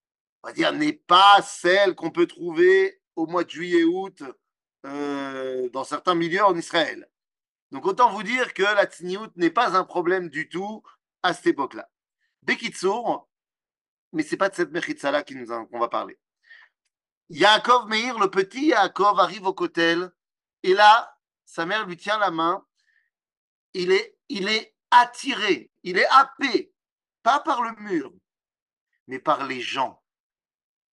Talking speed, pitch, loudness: 155 wpm, 205 Hz, -22 LUFS